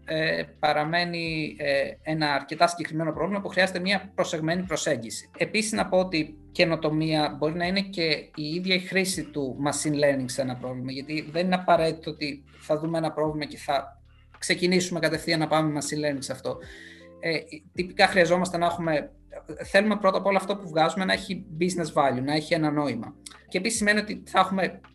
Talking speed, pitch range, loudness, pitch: 185 wpm, 150-180 Hz, -26 LUFS, 160 Hz